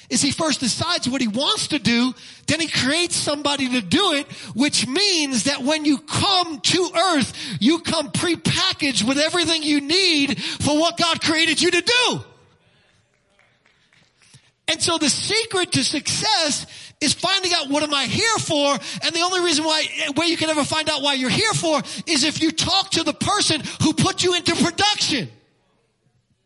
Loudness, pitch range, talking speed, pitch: -19 LUFS, 280-345 Hz, 180 wpm, 310 Hz